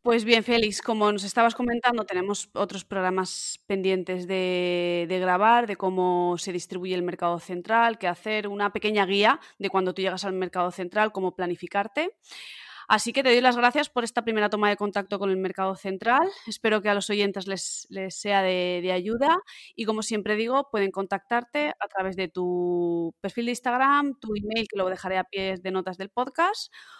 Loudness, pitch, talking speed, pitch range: -25 LUFS, 200 Hz, 190 wpm, 185-230 Hz